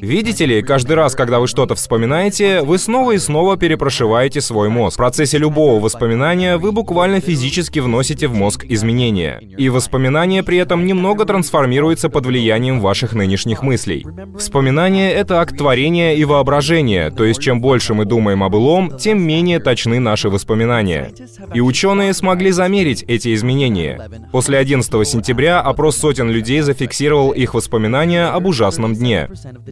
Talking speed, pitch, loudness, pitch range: 150 wpm, 135 Hz, -14 LUFS, 115-170 Hz